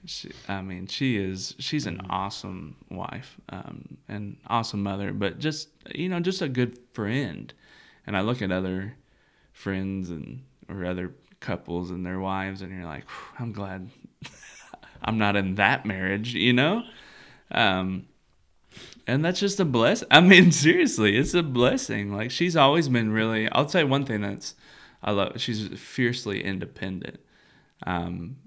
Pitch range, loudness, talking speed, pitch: 95-140 Hz, -24 LUFS, 155 wpm, 110 Hz